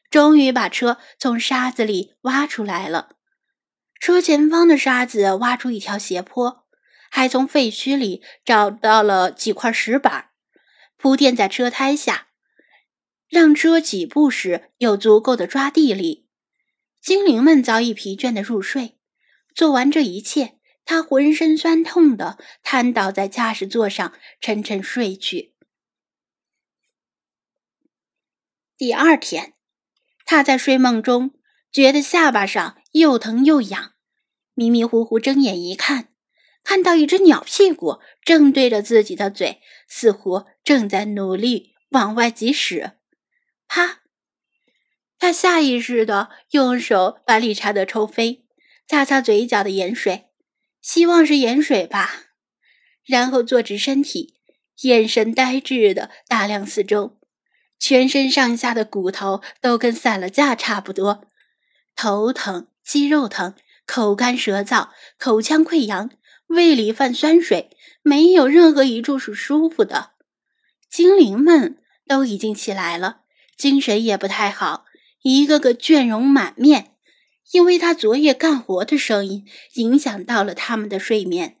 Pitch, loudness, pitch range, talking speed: 255 Hz, -17 LUFS, 215-295 Hz, 195 characters per minute